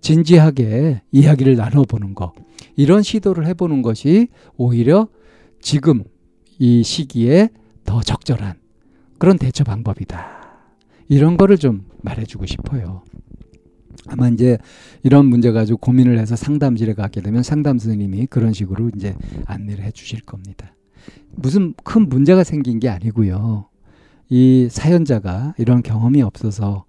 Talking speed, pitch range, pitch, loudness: 285 characters per minute, 105-145 Hz, 120 Hz, -15 LUFS